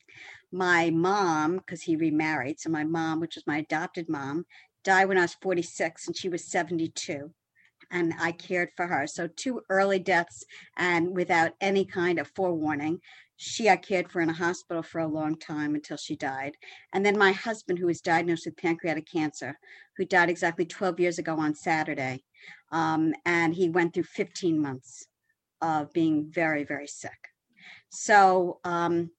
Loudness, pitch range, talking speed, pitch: -27 LUFS, 155-180 Hz, 170 wpm, 170 Hz